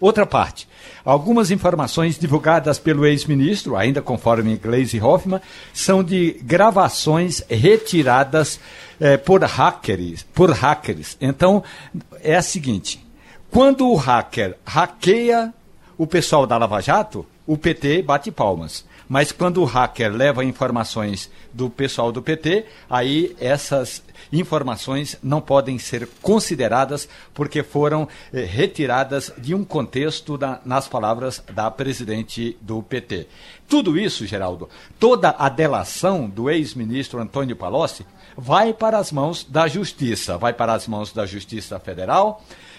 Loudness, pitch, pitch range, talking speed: -19 LUFS, 140 Hz, 120-170 Hz, 130 wpm